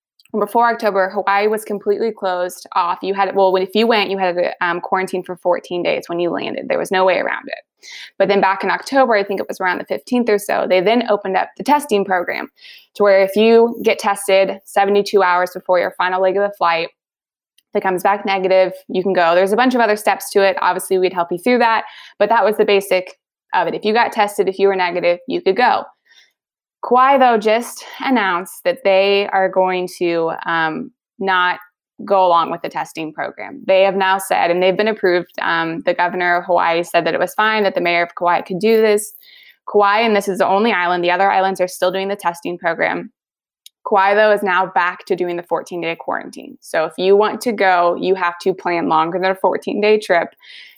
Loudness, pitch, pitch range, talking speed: -16 LUFS, 195 Hz, 180-210 Hz, 225 wpm